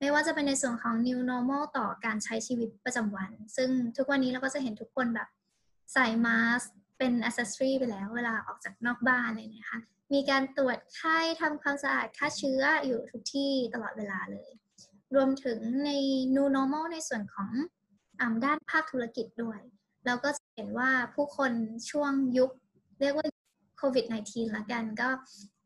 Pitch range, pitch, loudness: 230-275 Hz, 250 Hz, -31 LUFS